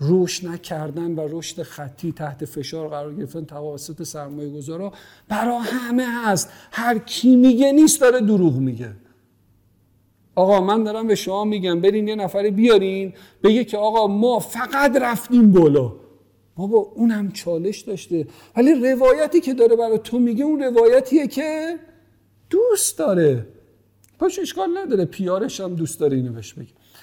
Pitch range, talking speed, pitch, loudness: 155-240 Hz, 145 wpm, 200 Hz, -19 LUFS